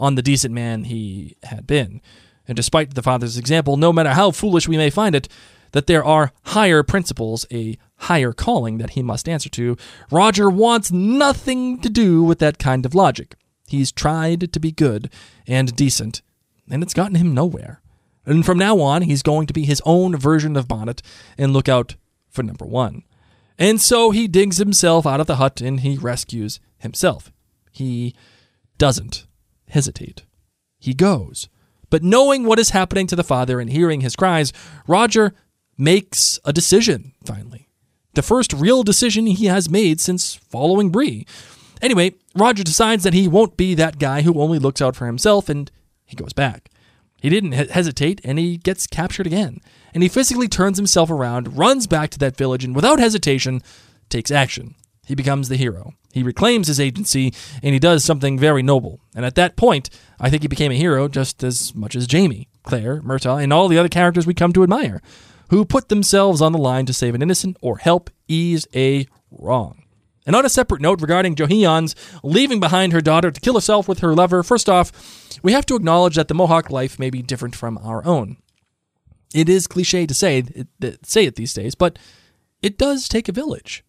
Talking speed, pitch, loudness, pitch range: 190 wpm, 155 Hz, -17 LUFS, 130-185 Hz